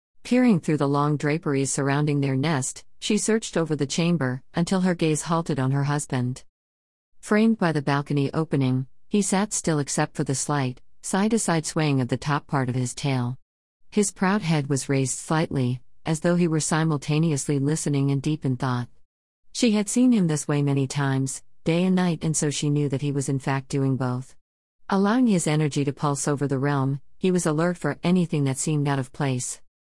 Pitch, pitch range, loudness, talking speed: 145 Hz, 135-165 Hz, -24 LUFS, 200 wpm